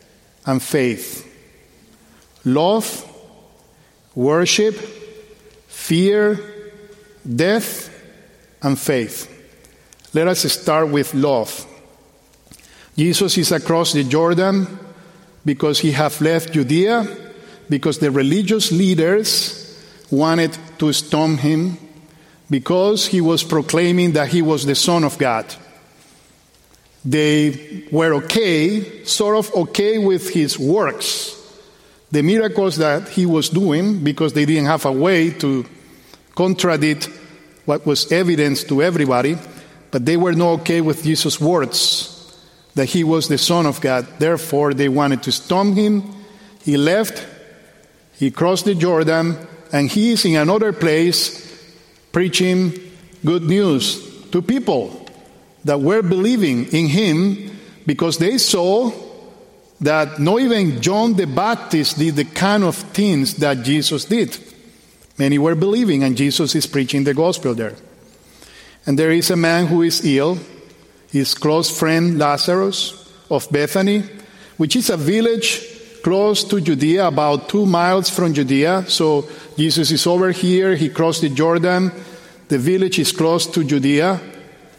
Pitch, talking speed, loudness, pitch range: 165 Hz, 130 wpm, -17 LUFS, 150-190 Hz